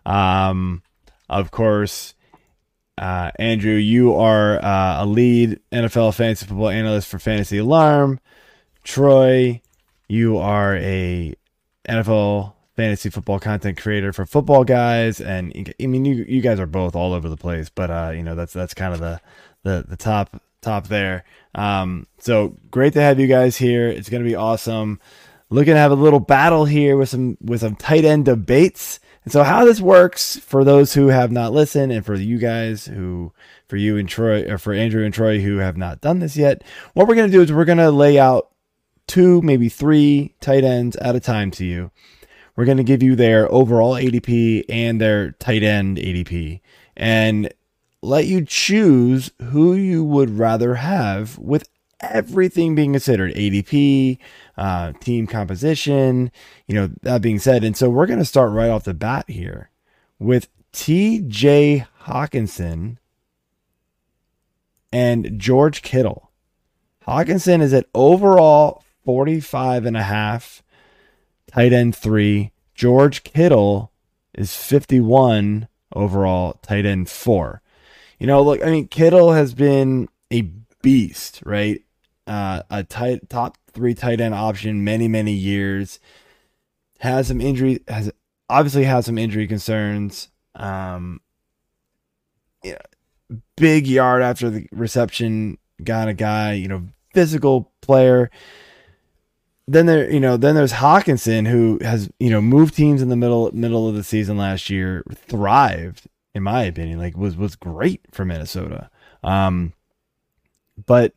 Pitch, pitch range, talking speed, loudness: 115 Hz, 100-135 Hz, 150 wpm, -17 LUFS